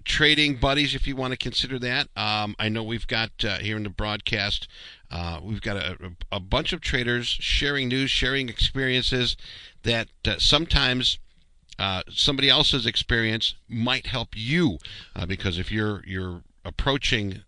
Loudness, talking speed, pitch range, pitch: -24 LUFS, 160 wpm, 100-130 Hz, 115 Hz